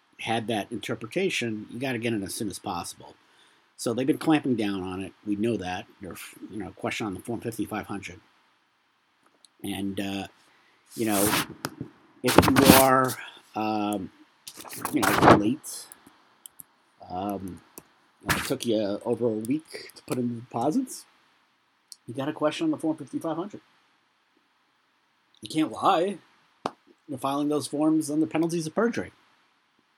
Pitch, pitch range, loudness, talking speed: 120 Hz, 105-155 Hz, -26 LUFS, 145 wpm